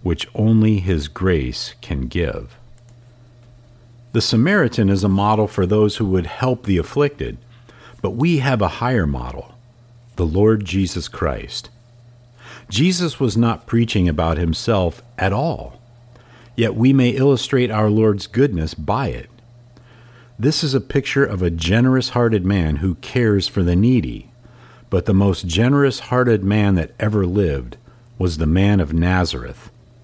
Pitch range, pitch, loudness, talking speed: 95-120 Hz, 115 Hz, -18 LUFS, 145 wpm